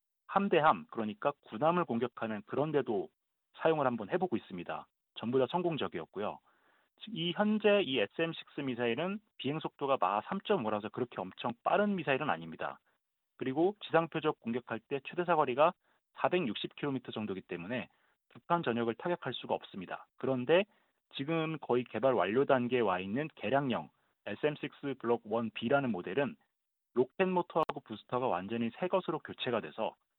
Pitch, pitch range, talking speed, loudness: 135 Hz, 115-170 Hz, 330 characters per minute, -34 LUFS